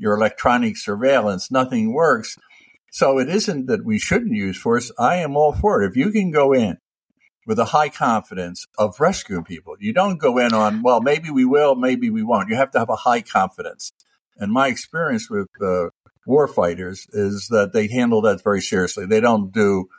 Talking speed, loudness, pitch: 200 wpm, -19 LUFS, 135 Hz